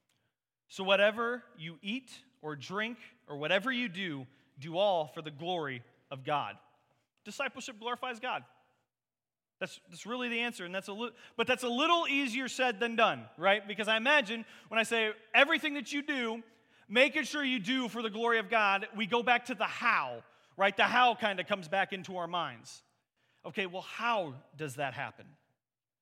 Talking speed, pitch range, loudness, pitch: 180 wpm, 170-245 Hz, -31 LUFS, 215 Hz